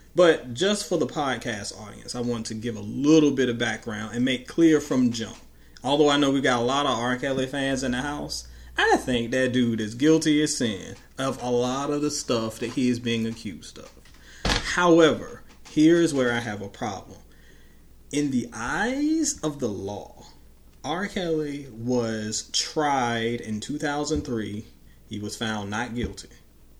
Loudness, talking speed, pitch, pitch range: -25 LUFS, 175 wpm, 120 Hz, 110-145 Hz